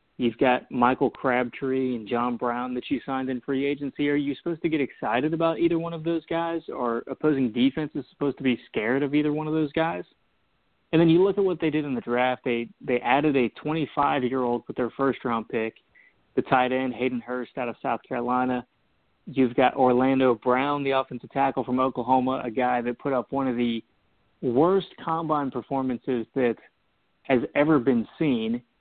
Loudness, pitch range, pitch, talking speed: -25 LUFS, 125-145 Hz, 130 Hz, 200 wpm